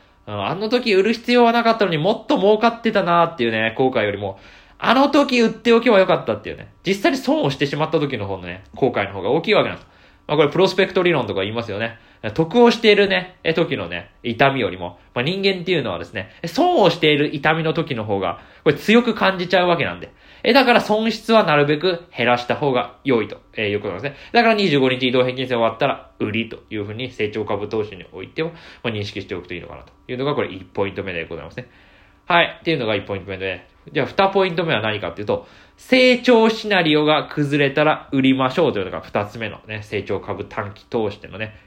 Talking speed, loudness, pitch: 460 characters per minute, -19 LUFS, 145 Hz